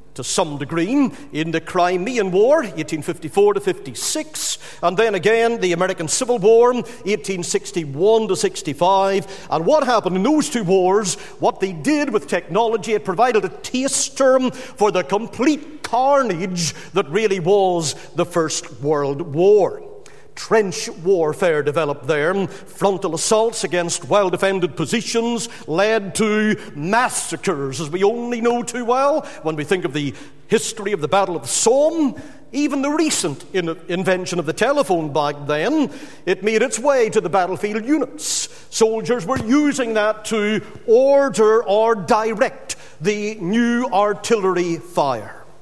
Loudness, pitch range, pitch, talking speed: -19 LUFS, 180-245 Hz, 210 Hz, 145 wpm